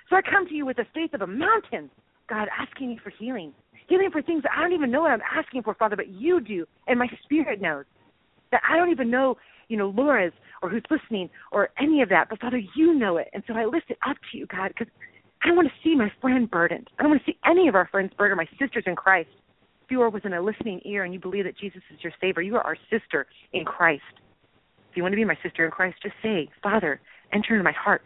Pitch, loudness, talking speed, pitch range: 225 Hz, -24 LUFS, 270 wpm, 190-295 Hz